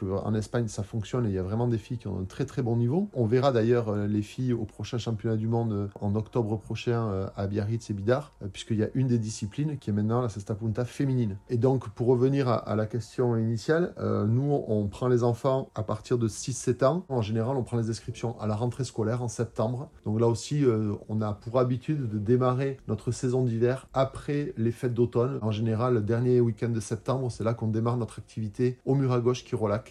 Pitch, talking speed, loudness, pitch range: 115 Hz, 225 wpm, -28 LUFS, 110-125 Hz